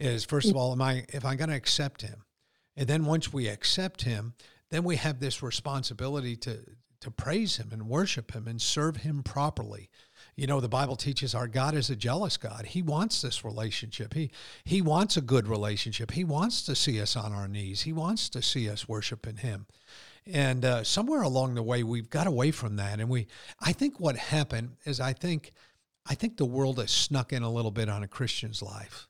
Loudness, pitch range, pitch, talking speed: -30 LUFS, 115-150 Hz, 130 Hz, 215 wpm